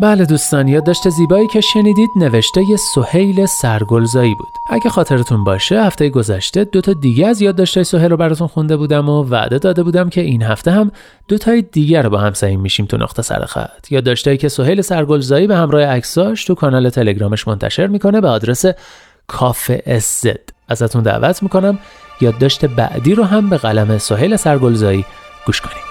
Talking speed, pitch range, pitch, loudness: 180 wpm, 120-190 Hz, 155 Hz, -13 LUFS